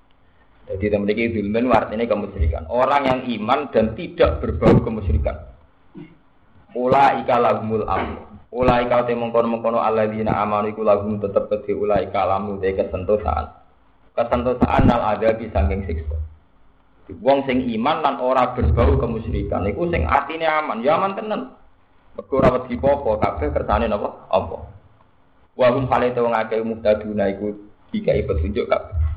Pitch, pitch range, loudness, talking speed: 110 Hz, 95-125 Hz, -20 LUFS, 140 wpm